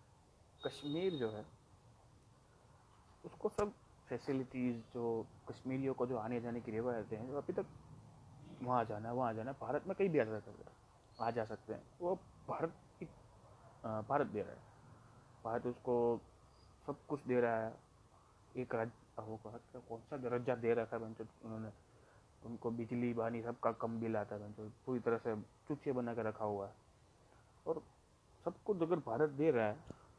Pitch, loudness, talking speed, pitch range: 115 Hz, -41 LUFS, 165 wpm, 110-130 Hz